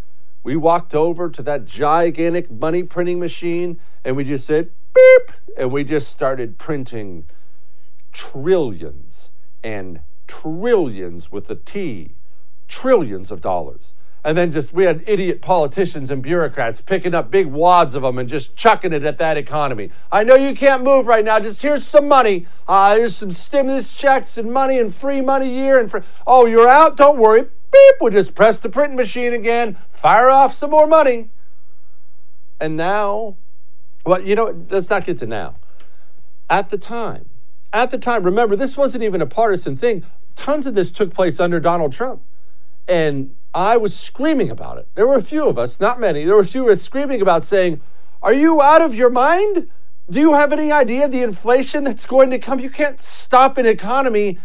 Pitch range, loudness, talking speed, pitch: 160-260 Hz, -15 LUFS, 185 wpm, 200 Hz